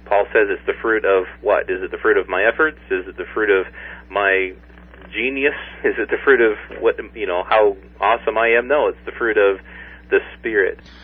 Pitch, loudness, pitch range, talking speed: 395 Hz, -18 LUFS, 345-430 Hz, 220 wpm